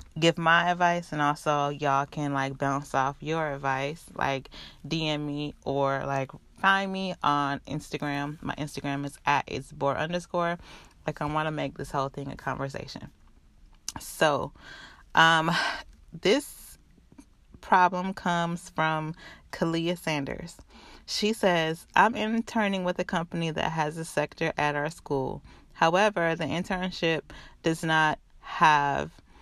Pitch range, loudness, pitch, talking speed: 140-170 Hz, -27 LUFS, 155 Hz, 135 wpm